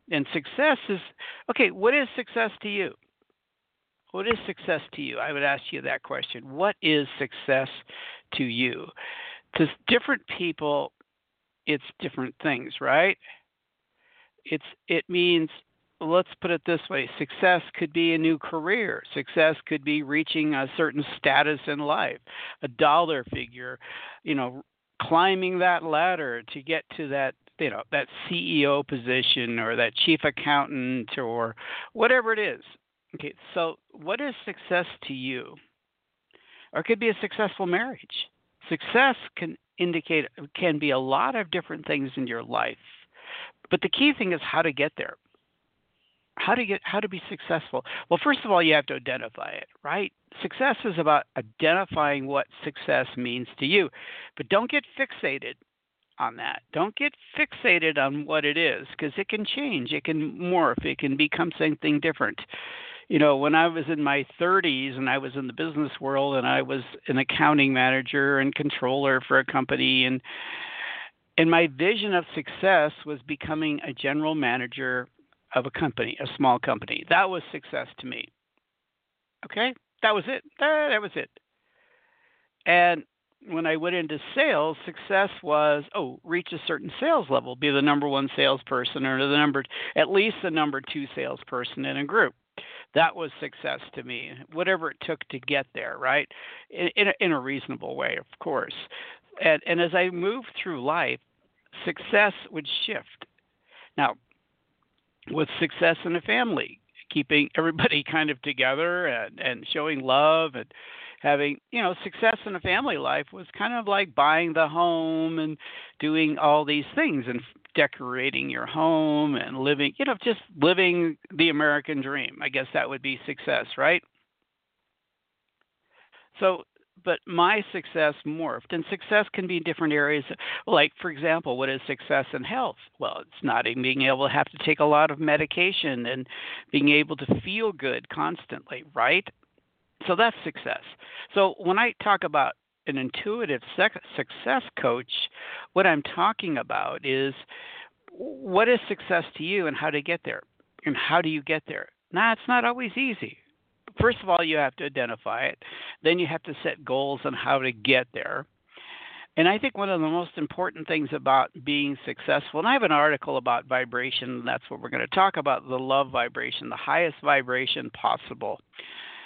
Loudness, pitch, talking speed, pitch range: -25 LUFS, 160 Hz, 170 wpm, 140-195 Hz